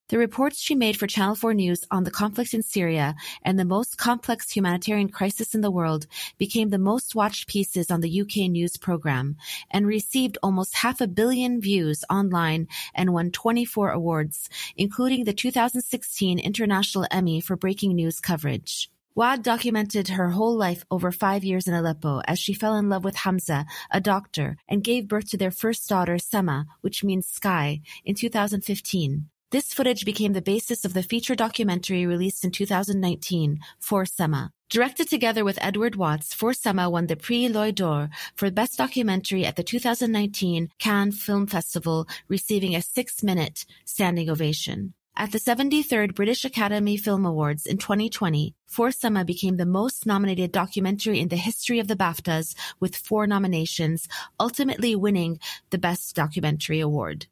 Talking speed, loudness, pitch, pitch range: 160 wpm, -25 LUFS, 195 Hz, 175-220 Hz